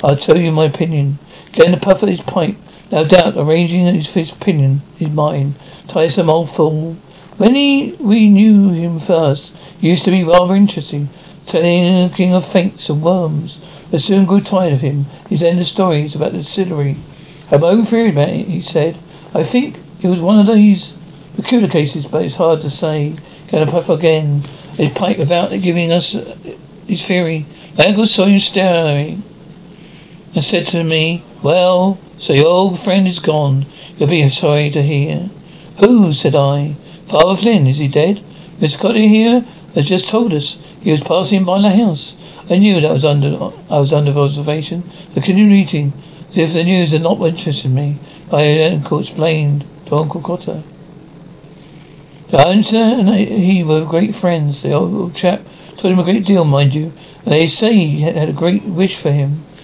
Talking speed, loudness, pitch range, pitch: 185 wpm, -13 LUFS, 155-185 Hz, 170 Hz